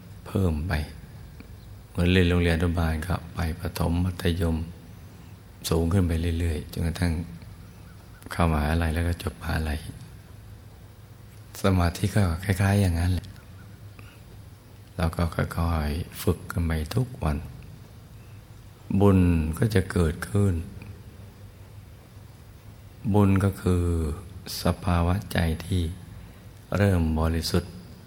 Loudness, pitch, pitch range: -26 LUFS, 95 Hz, 85-105 Hz